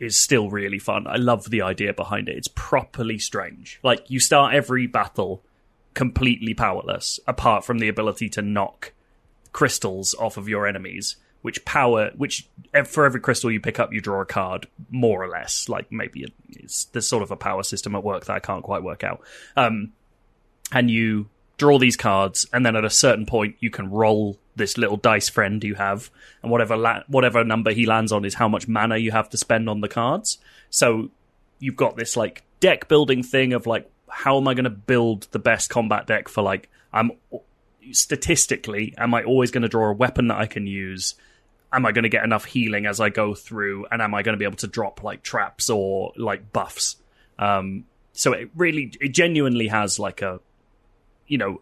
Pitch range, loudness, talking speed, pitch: 105-125 Hz, -22 LUFS, 205 wpm, 110 Hz